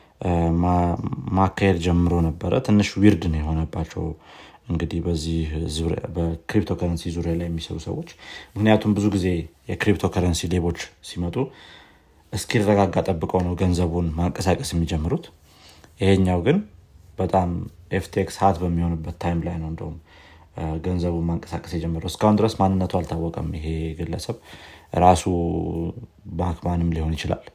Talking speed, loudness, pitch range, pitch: 105 wpm, -23 LUFS, 85-95 Hz, 85 Hz